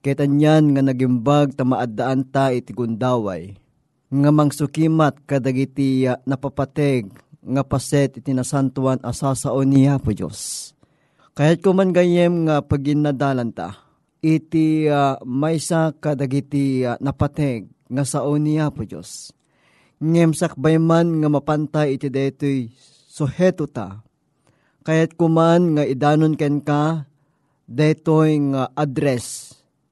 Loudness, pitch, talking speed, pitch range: -19 LUFS, 145 Hz, 120 wpm, 130-155 Hz